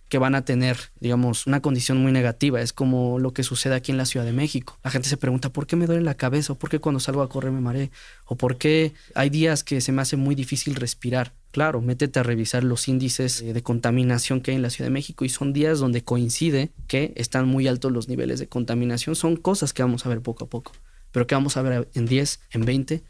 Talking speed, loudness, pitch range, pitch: 250 wpm, -23 LUFS, 125-140 Hz, 130 Hz